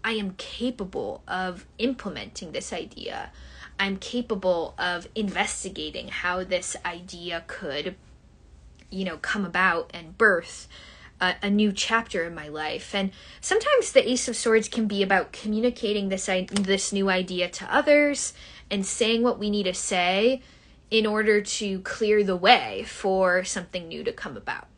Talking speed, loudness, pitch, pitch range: 155 wpm, -25 LUFS, 200 Hz, 180-220 Hz